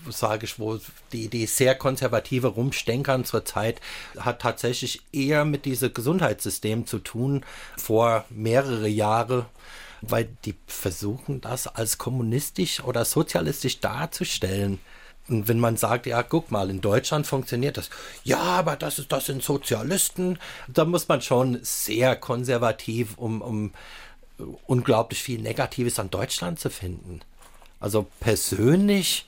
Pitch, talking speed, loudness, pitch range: 120 Hz, 135 wpm, -25 LUFS, 110-135 Hz